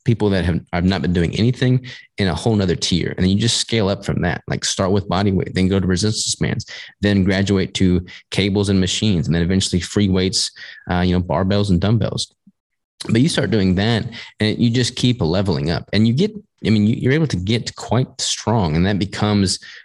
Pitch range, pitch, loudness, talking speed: 95-115 Hz, 100 Hz, -18 LUFS, 220 wpm